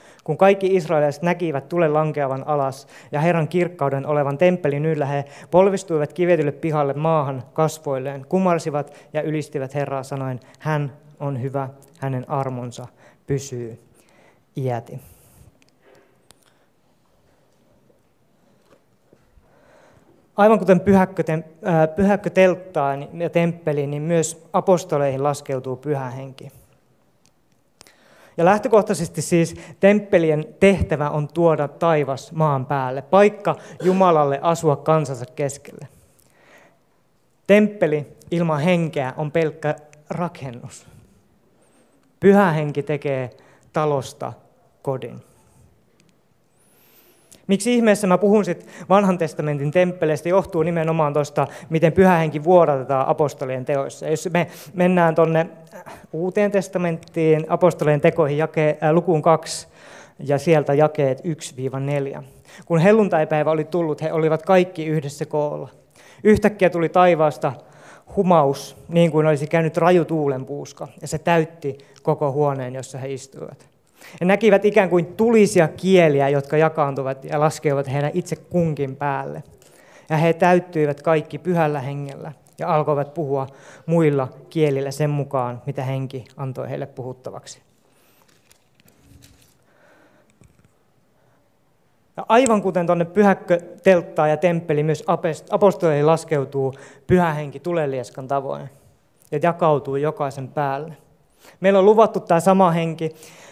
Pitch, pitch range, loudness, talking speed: 155 Hz, 140-175 Hz, -20 LUFS, 105 wpm